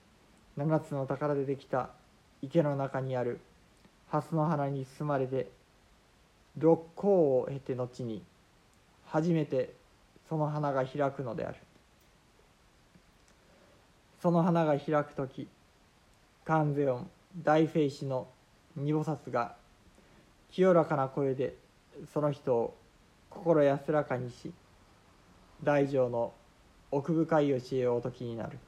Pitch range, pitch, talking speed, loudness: 130-155 Hz, 140 Hz, 190 characters per minute, -31 LUFS